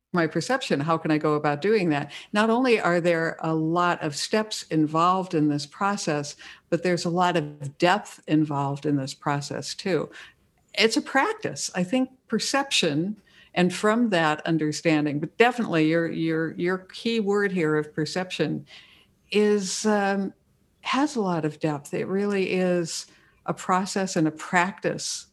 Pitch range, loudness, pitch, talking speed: 155-205 Hz, -25 LUFS, 175 Hz, 160 wpm